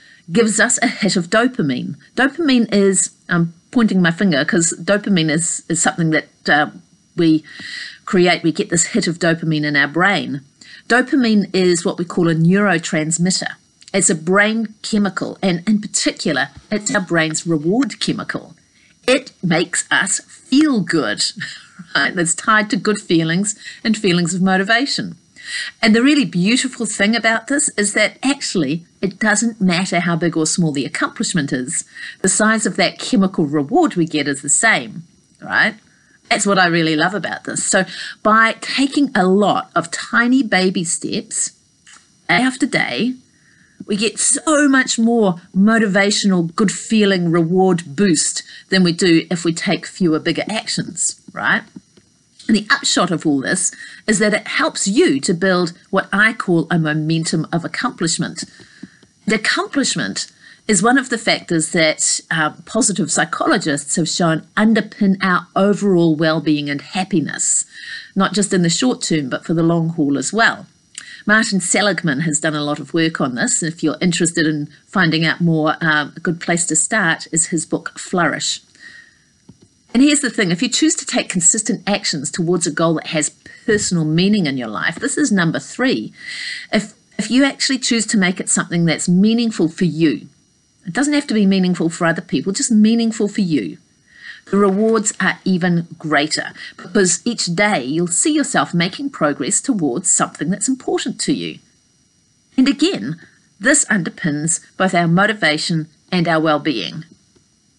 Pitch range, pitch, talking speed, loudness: 165-225 Hz, 190 Hz, 165 wpm, -16 LUFS